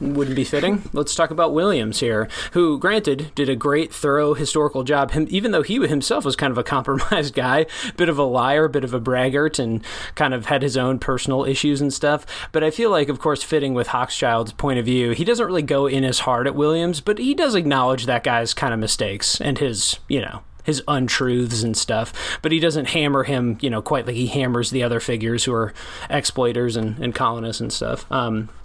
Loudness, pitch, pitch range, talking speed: -20 LUFS, 135 Hz, 120-150 Hz, 220 wpm